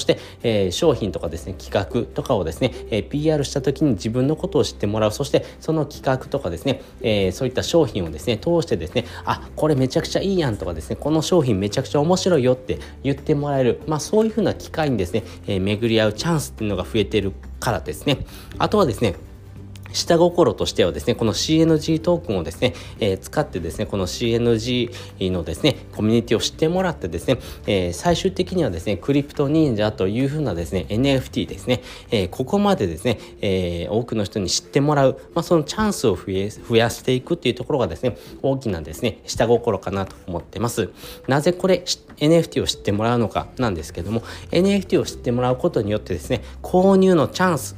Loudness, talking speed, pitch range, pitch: -21 LUFS, 455 characters per minute, 100-155 Hz, 120 Hz